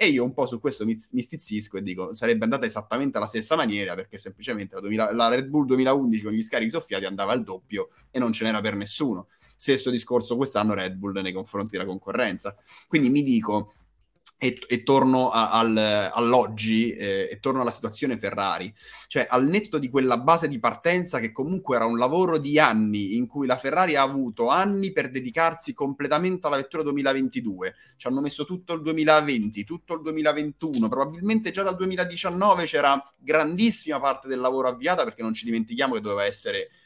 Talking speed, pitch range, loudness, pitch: 185 wpm, 115-160 Hz, -24 LUFS, 135 Hz